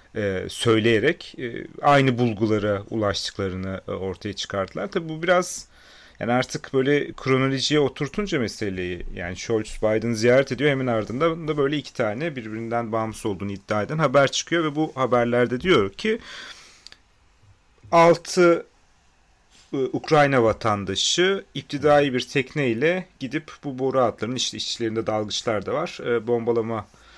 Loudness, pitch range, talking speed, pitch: -23 LUFS, 110-145 Hz, 130 wpm, 125 Hz